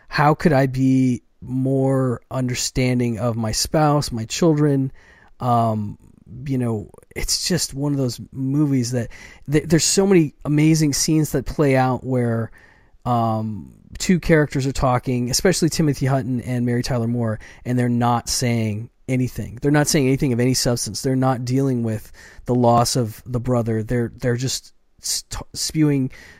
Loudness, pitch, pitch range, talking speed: -20 LUFS, 125 Hz, 120-140 Hz, 155 wpm